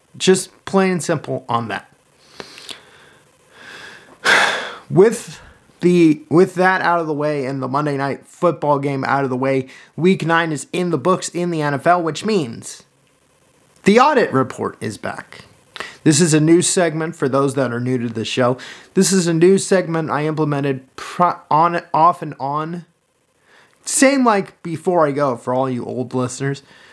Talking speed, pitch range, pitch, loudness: 165 wpm, 135-175 Hz, 155 Hz, -17 LUFS